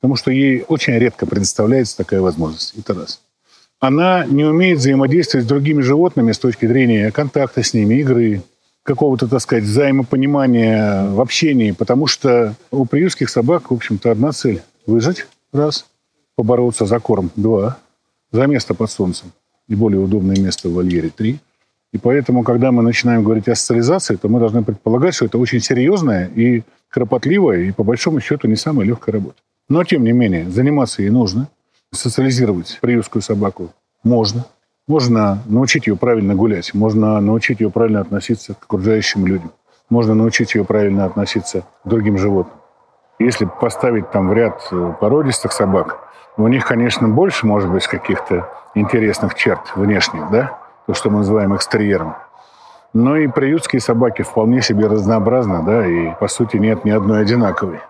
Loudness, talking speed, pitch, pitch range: -15 LUFS, 160 wpm, 115 Hz, 105-130 Hz